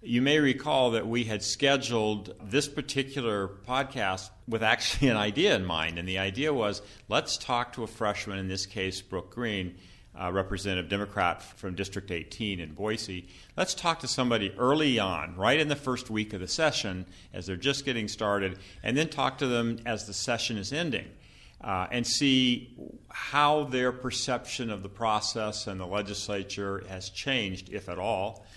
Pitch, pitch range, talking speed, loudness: 105 Hz, 95-125 Hz, 175 wpm, -29 LUFS